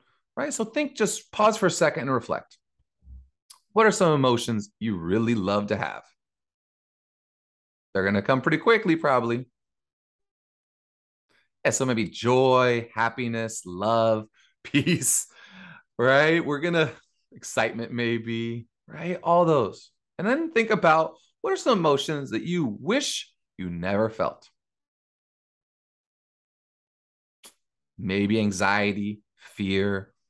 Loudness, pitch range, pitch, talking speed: -24 LUFS, 95-160 Hz, 115 Hz, 115 wpm